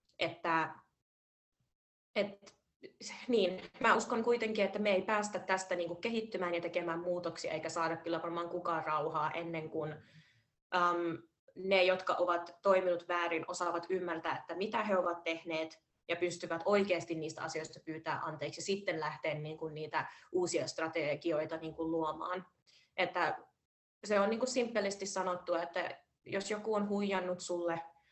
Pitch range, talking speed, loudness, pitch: 160-190 Hz, 140 wpm, -36 LUFS, 175 Hz